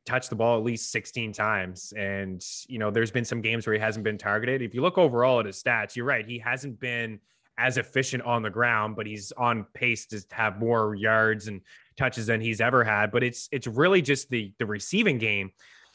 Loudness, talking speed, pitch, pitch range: -26 LUFS, 220 wpm, 115 Hz, 110-125 Hz